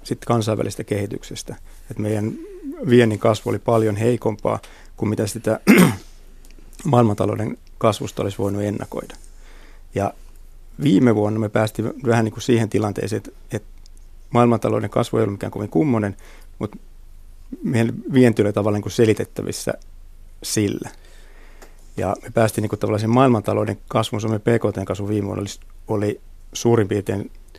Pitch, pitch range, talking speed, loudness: 105 Hz, 95-115 Hz, 135 wpm, -21 LUFS